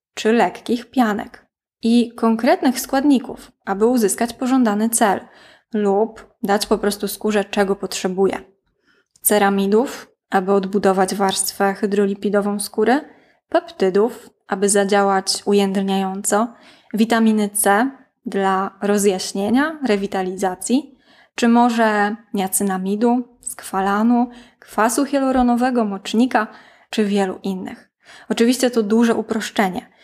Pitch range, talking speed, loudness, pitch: 200-240 Hz, 90 wpm, -19 LUFS, 215 Hz